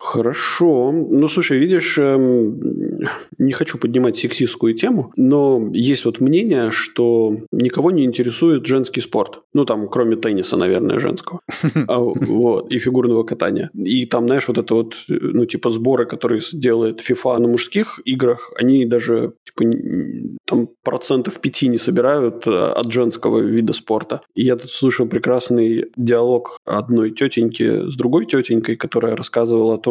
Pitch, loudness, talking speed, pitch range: 120 Hz, -17 LUFS, 145 wpm, 115-130 Hz